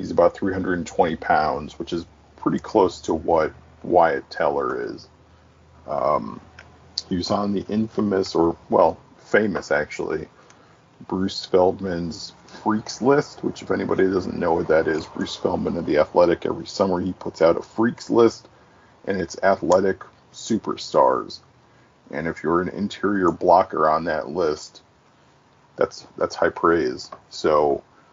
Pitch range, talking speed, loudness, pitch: 90-105 Hz, 140 wpm, -22 LUFS, 95 Hz